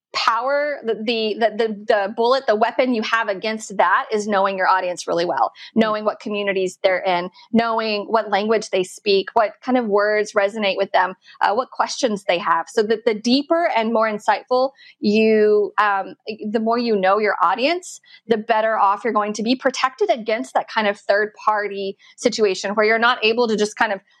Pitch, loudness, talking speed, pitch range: 220 Hz, -19 LUFS, 195 wpm, 205-235 Hz